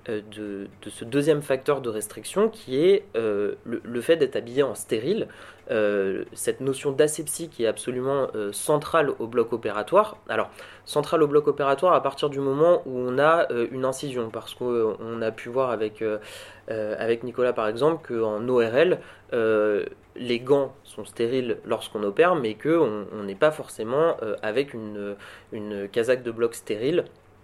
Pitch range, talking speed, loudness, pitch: 110-150 Hz, 170 wpm, -25 LUFS, 125 Hz